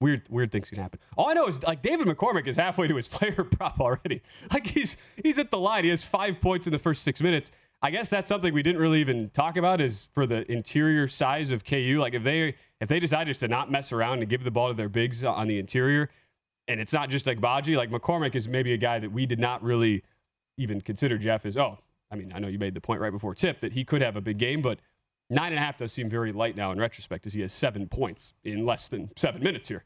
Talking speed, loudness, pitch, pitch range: 270 wpm, -27 LUFS, 125 Hz, 110-150 Hz